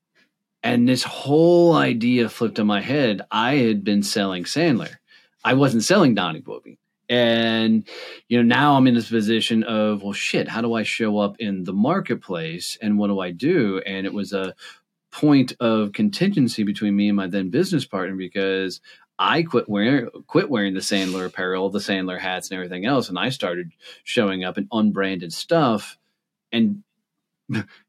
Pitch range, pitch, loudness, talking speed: 95-125 Hz, 105 Hz, -21 LUFS, 170 wpm